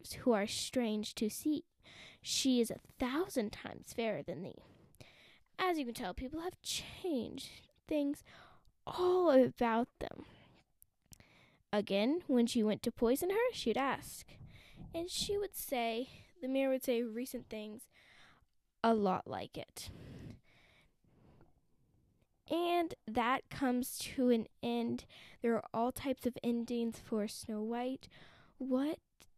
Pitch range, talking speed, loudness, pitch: 225-280 Hz, 130 wpm, -36 LUFS, 245 Hz